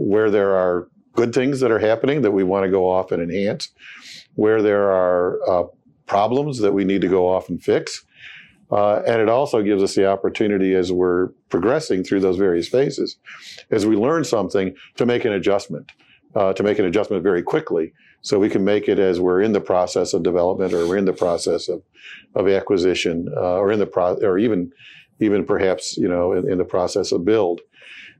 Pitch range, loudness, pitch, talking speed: 90-100 Hz, -19 LUFS, 95 Hz, 205 wpm